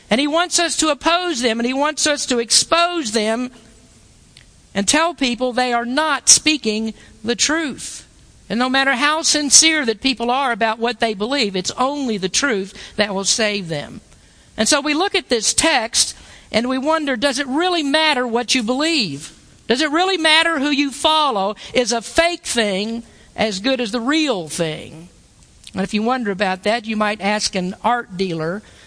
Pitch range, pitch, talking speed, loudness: 215-300 Hz, 245 Hz, 185 wpm, -17 LUFS